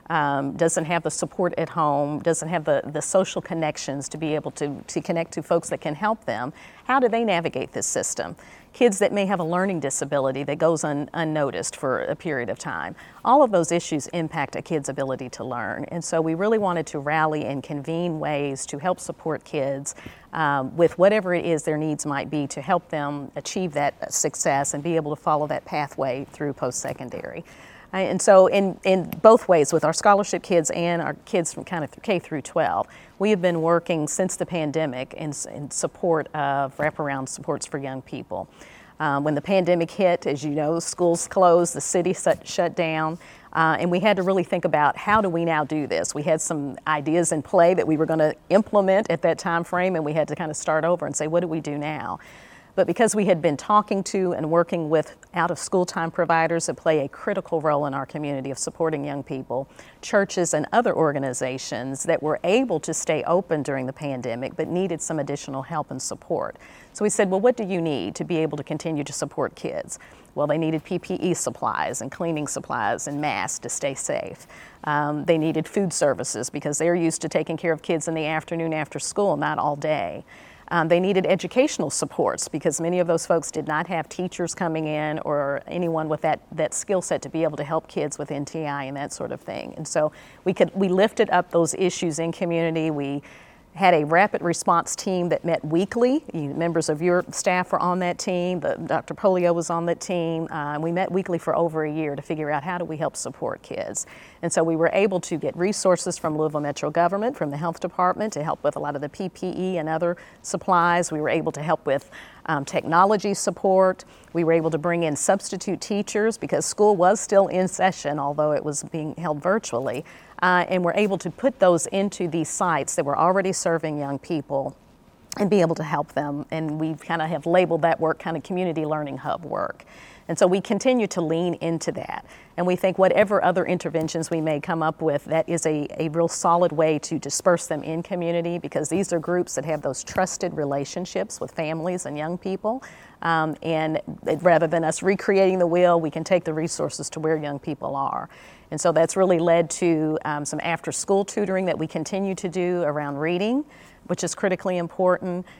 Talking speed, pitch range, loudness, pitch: 215 wpm, 150-180 Hz, -23 LUFS, 165 Hz